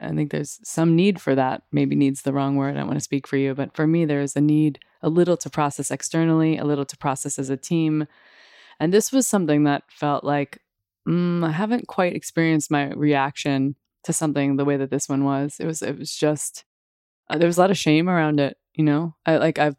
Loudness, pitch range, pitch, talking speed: -22 LUFS, 140-160 Hz, 150 Hz, 230 wpm